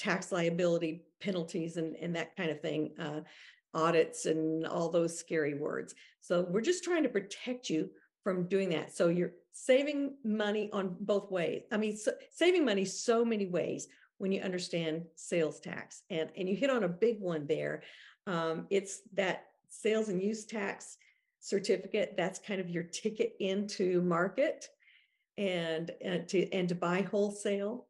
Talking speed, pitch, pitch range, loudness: 165 wpm, 185 Hz, 170-210 Hz, -34 LUFS